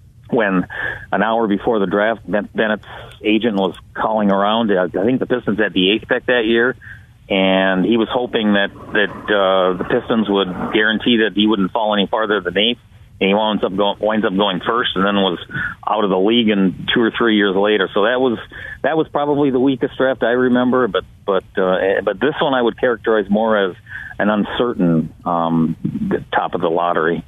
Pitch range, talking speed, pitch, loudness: 95-115 Hz, 195 wpm, 105 Hz, -17 LUFS